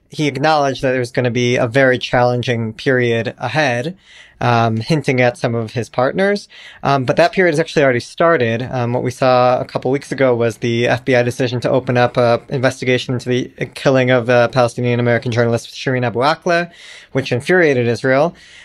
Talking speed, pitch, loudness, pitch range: 185 wpm, 125 Hz, -16 LUFS, 120-140 Hz